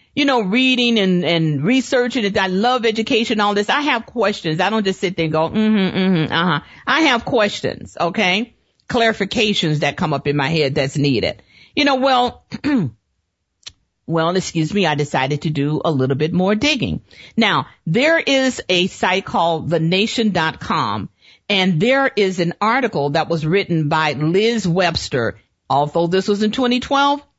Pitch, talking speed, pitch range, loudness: 190 Hz, 170 wpm, 160-230 Hz, -17 LUFS